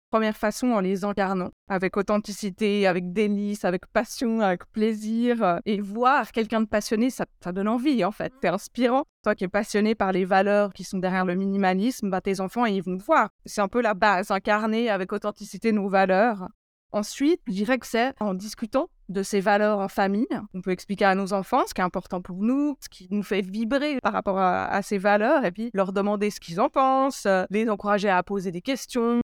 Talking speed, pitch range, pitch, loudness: 210 wpm, 195-225 Hz, 205 Hz, -25 LUFS